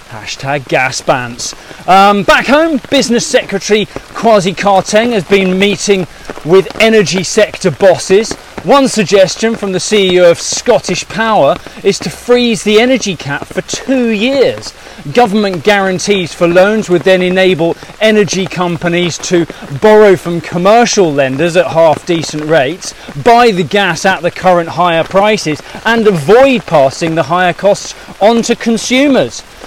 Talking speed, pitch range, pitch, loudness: 140 wpm, 175-215 Hz, 190 Hz, -10 LUFS